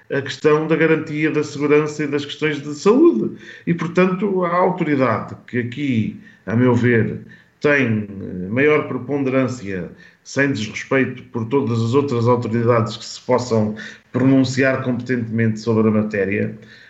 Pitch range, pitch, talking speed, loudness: 115-150 Hz, 130 Hz, 135 wpm, -19 LUFS